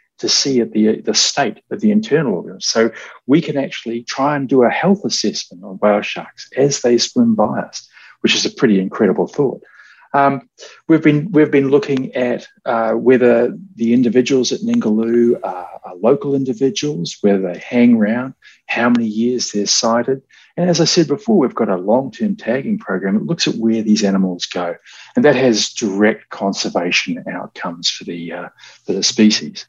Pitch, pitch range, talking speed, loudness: 125 Hz, 115-150 Hz, 185 wpm, -16 LUFS